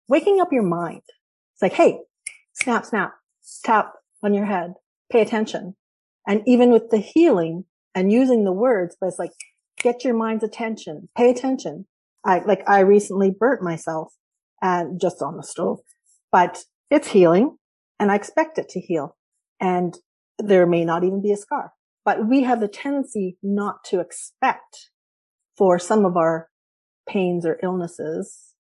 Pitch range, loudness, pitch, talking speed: 180-240 Hz, -21 LUFS, 200 Hz, 160 wpm